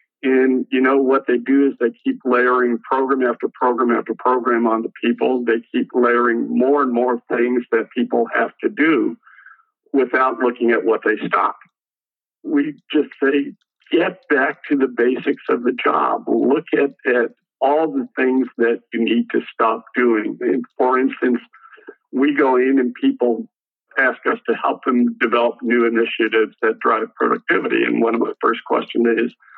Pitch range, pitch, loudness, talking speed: 120-140 Hz, 125 Hz, -18 LUFS, 170 wpm